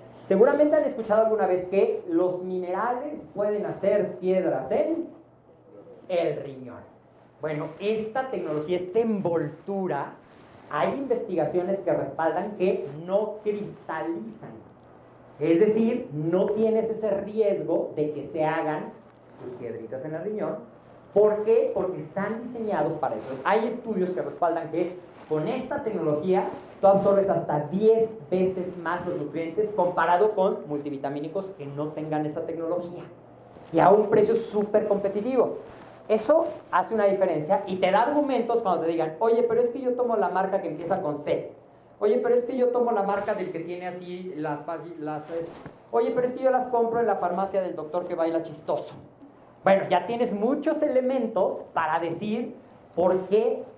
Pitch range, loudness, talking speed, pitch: 165-225 Hz, -26 LUFS, 155 wpm, 195 Hz